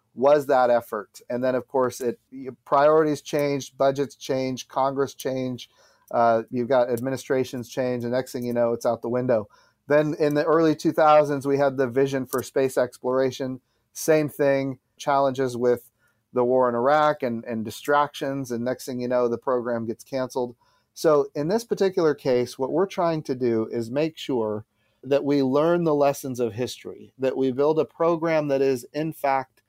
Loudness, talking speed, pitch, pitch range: -24 LUFS, 180 wpm, 130 Hz, 125-145 Hz